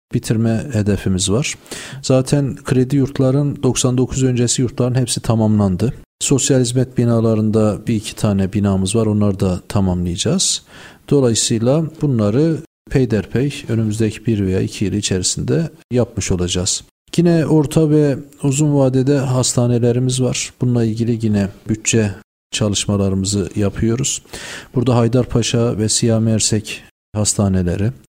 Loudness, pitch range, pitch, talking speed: -17 LUFS, 105-130 Hz, 115 Hz, 110 wpm